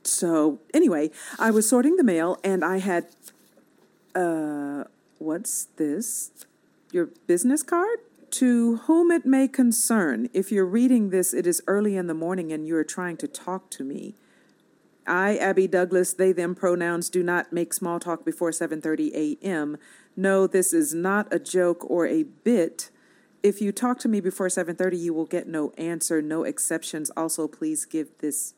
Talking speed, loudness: 170 wpm, -24 LUFS